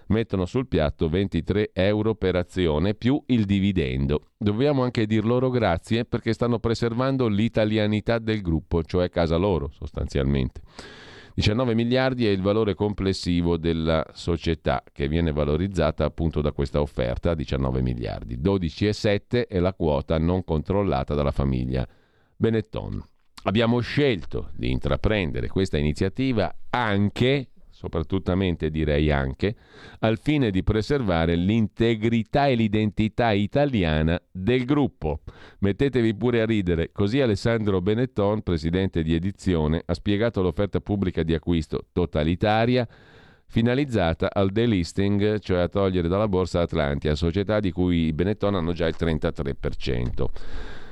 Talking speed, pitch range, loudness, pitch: 125 wpm, 80-110 Hz, -24 LUFS, 95 Hz